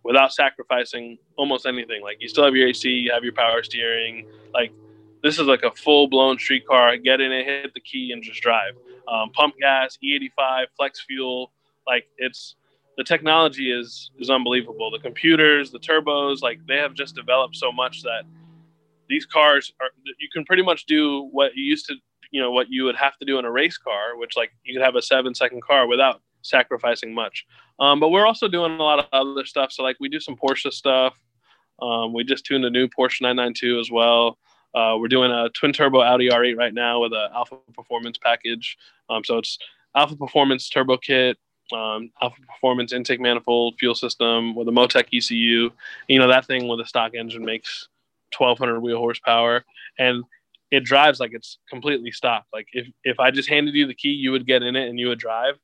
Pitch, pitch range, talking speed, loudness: 130 Hz, 120-140 Hz, 210 wpm, -20 LUFS